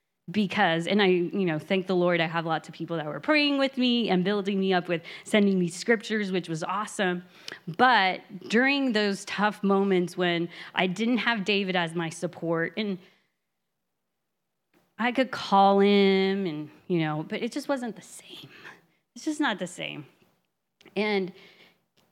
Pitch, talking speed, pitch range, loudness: 195 Hz, 170 wpm, 175-215 Hz, -26 LUFS